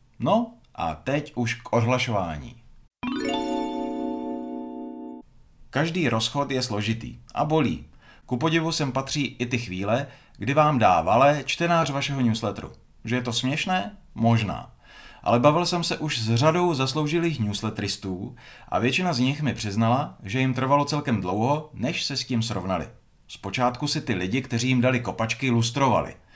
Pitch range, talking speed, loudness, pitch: 110-145 Hz, 145 wpm, -25 LUFS, 125 Hz